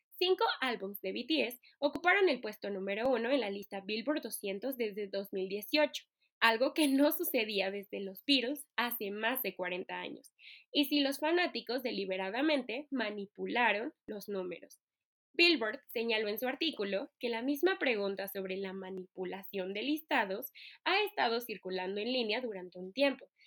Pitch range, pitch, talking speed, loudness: 195-285 Hz, 230 Hz, 150 wpm, -34 LUFS